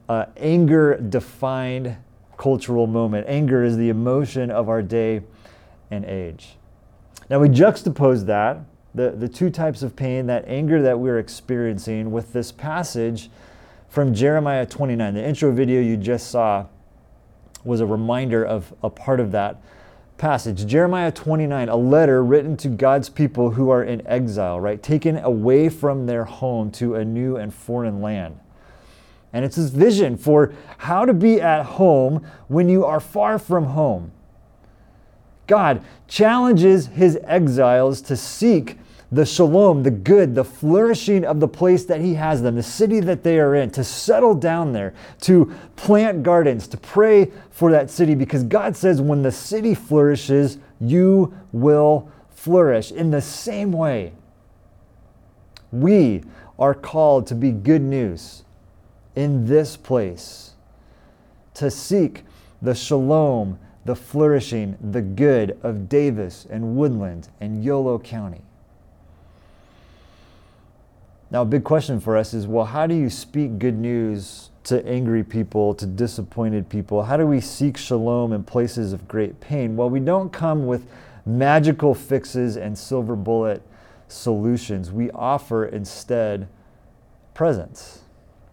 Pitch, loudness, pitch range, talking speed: 125 Hz, -19 LUFS, 110-150 Hz, 145 wpm